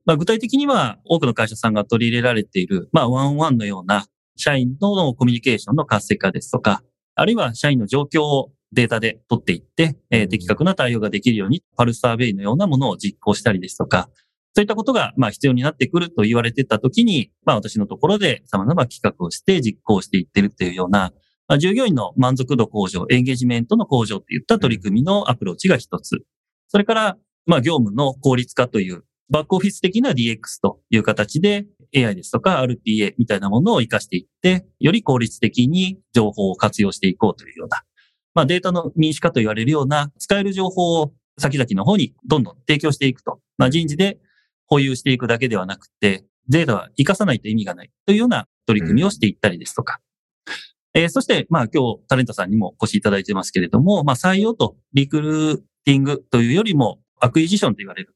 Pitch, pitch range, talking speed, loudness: 130 Hz, 110-165 Hz, 440 characters per minute, -19 LUFS